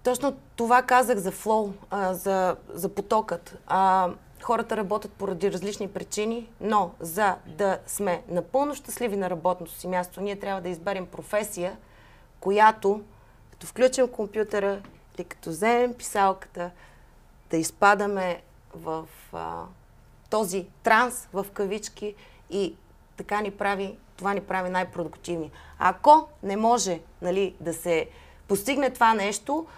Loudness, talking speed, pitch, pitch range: -26 LUFS, 125 wpm, 195 Hz, 180-215 Hz